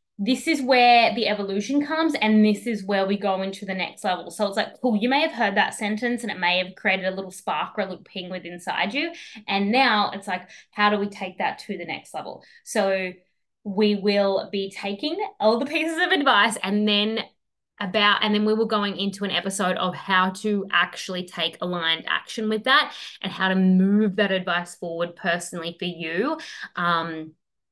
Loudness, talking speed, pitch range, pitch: -23 LUFS, 205 wpm, 185-220 Hz, 200 Hz